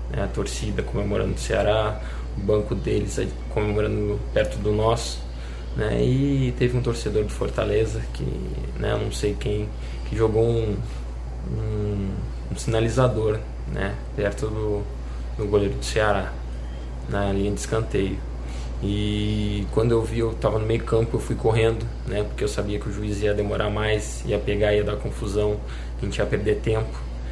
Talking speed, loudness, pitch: 160 wpm, -25 LUFS, 105 Hz